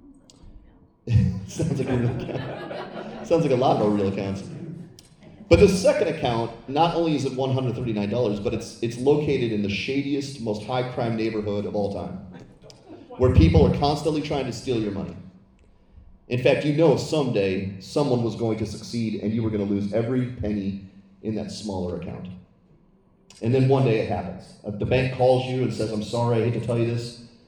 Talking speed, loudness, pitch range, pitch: 190 wpm, -24 LUFS, 105-130 Hz, 115 Hz